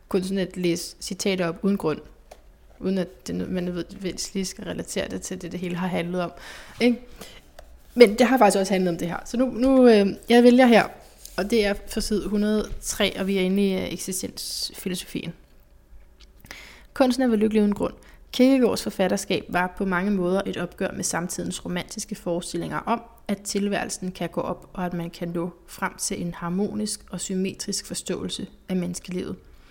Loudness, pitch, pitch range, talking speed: -24 LUFS, 190 Hz, 180-210 Hz, 180 wpm